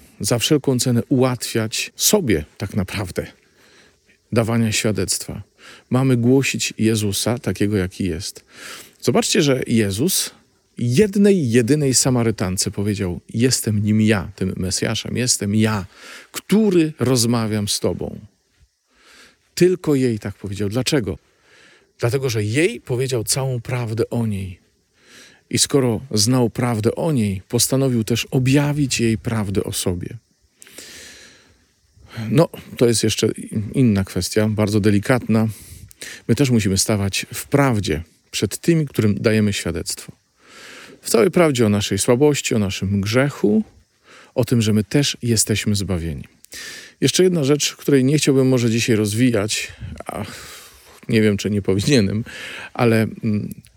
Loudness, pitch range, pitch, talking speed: -19 LUFS, 105-130 Hz, 110 Hz, 125 wpm